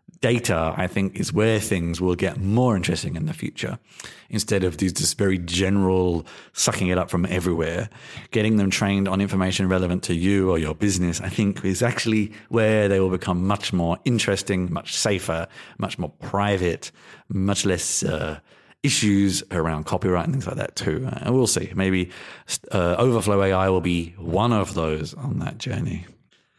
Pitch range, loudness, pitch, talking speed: 90-105 Hz, -23 LUFS, 95 Hz, 170 wpm